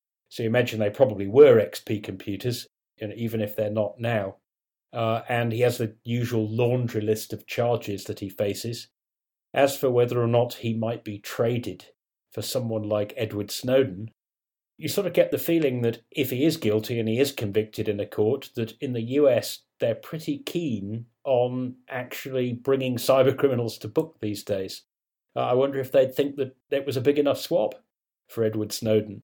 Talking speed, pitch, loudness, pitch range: 190 wpm, 120 Hz, -25 LUFS, 110-130 Hz